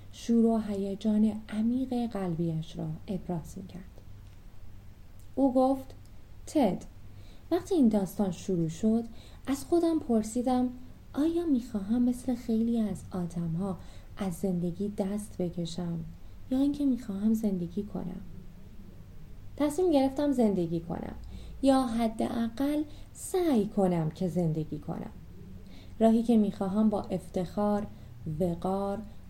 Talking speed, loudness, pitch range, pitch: 105 wpm, -30 LUFS, 170-235 Hz, 200 Hz